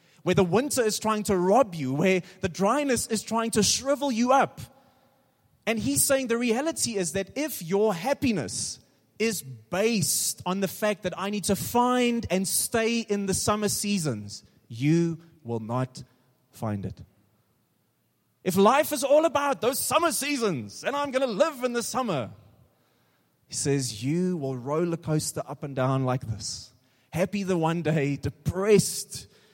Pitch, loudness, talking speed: 185 Hz, -26 LUFS, 160 wpm